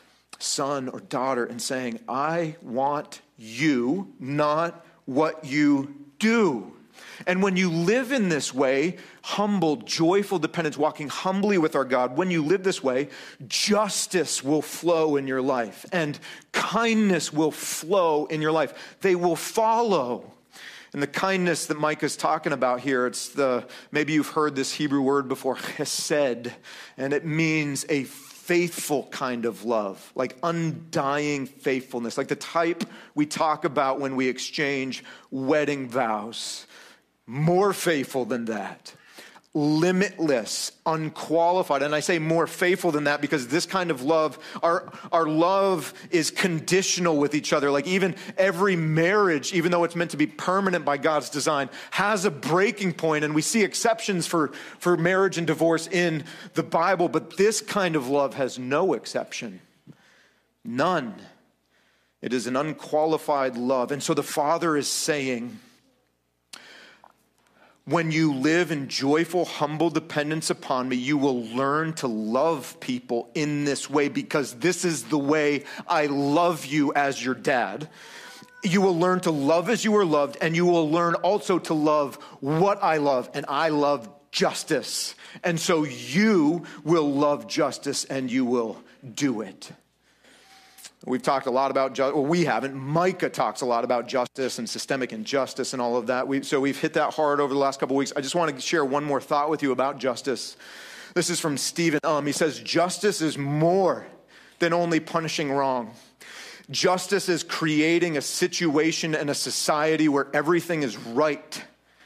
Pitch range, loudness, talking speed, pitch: 140-170 Hz, -24 LUFS, 160 wpm, 155 Hz